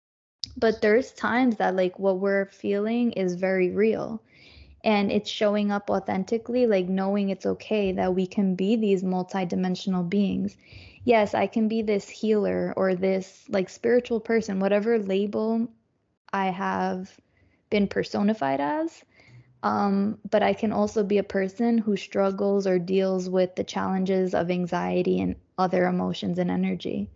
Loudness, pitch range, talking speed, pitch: -25 LUFS, 185-215 Hz, 150 wpm, 195 Hz